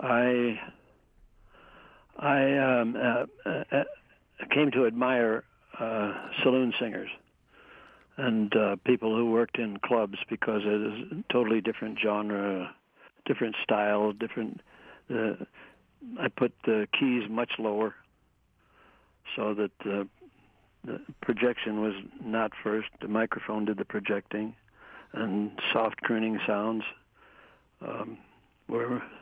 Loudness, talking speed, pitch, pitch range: -29 LUFS, 110 wpm, 110 Hz, 105-120 Hz